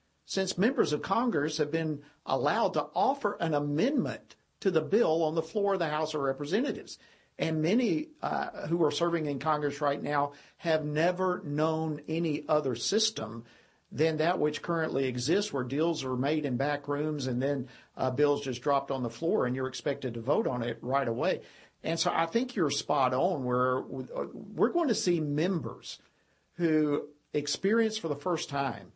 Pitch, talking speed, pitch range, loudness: 150 Hz, 180 wpm, 140-170 Hz, -30 LUFS